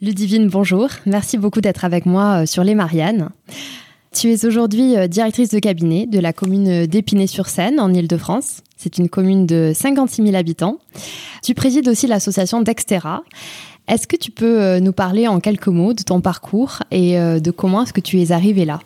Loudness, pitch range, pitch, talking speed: -16 LUFS, 180-220 Hz, 195 Hz, 175 wpm